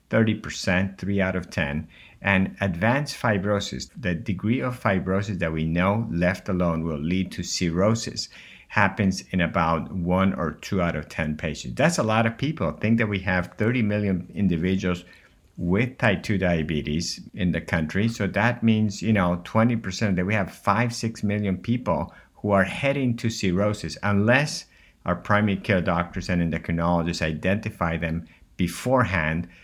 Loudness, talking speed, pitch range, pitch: -24 LUFS, 155 wpm, 85-110 Hz, 95 Hz